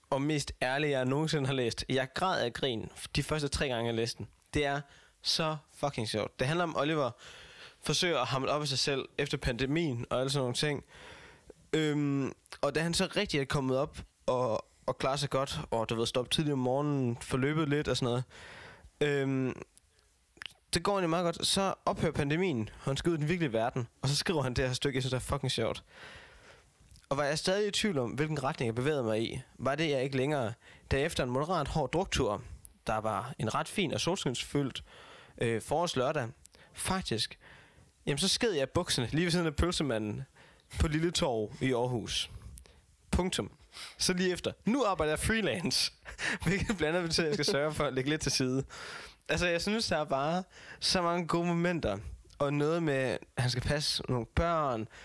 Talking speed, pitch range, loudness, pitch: 205 wpm, 125-155 Hz, -32 LUFS, 140 Hz